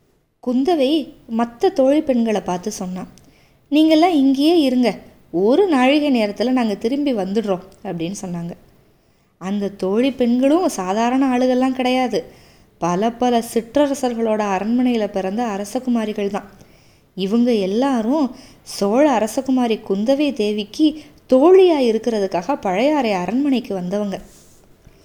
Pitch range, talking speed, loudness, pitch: 200-270 Hz, 100 wpm, -18 LUFS, 235 Hz